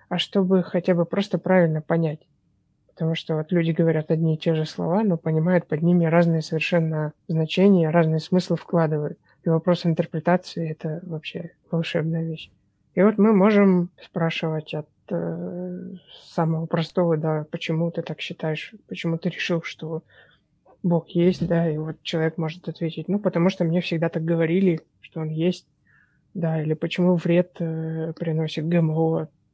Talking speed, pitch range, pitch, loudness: 155 wpm, 160-175 Hz, 165 Hz, -23 LUFS